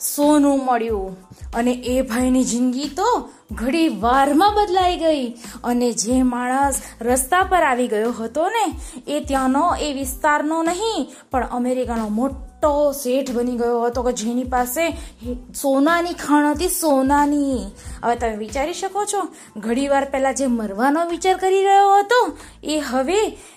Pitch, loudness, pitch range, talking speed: 275 Hz, -19 LUFS, 245-325 Hz, 135 wpm